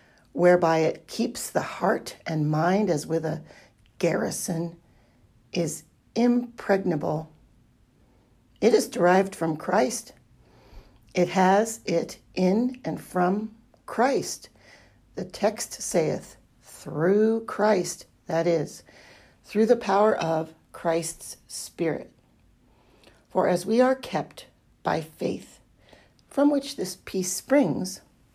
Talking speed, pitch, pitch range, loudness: 105 wpm, 175 Hz, 160-210 Hz, -25 LUFS